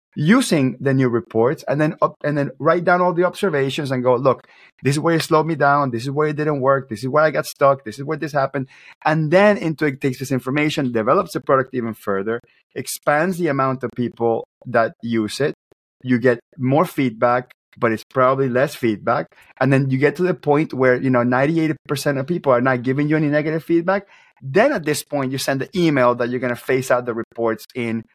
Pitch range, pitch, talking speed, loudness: 125-155 Hz, 135 Hz, 230 wpm, -19 LUFS